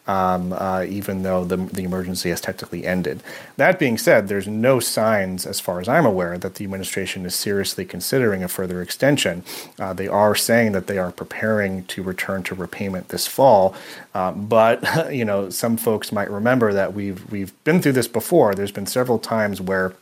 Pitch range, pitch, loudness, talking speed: 95-105 Hz, 95 Hz, -20 LUFS, 190 wpm